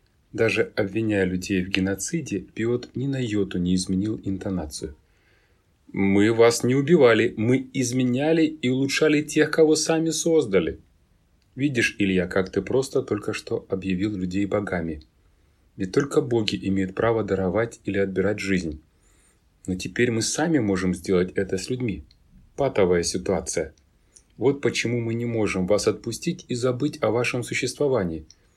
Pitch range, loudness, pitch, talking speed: 95-125 Hz, -23 LUFS, 100 Hz, 140 wpm